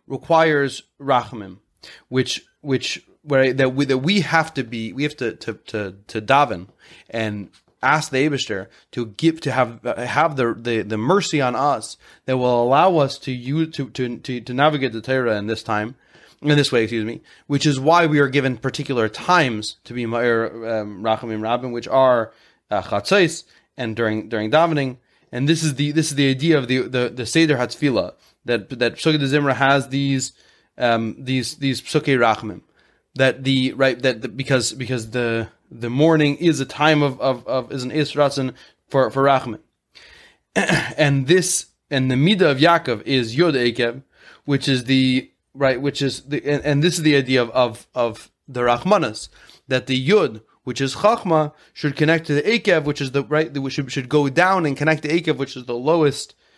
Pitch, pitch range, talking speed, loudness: 135 Hz, 120-150 Hz, 190 wpm, -20 LUFS